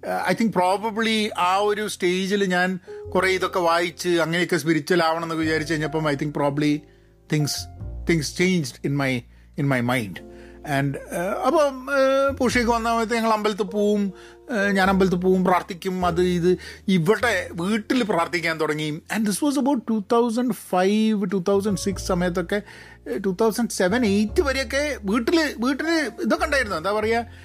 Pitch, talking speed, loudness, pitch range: 190 Hz, 140 wpm, -22 LUFS, 170-225 Hz